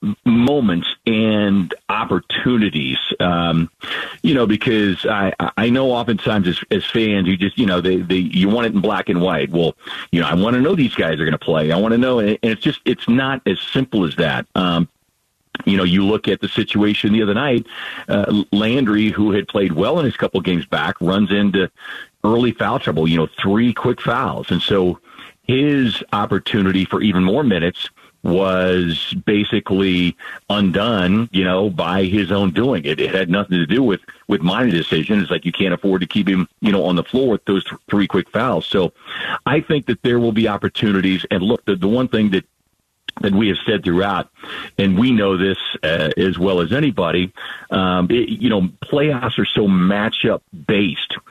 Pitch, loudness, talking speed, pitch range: 100 Hz, -17 LUFS, 200 wpm, 95-115 Hz